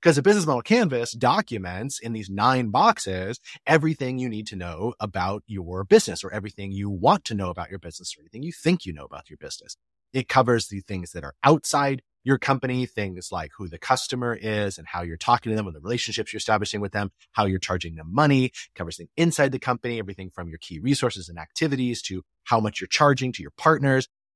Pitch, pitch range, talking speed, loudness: 110 Hz, 95-130 Hz, 220 wpm, -24 LUFS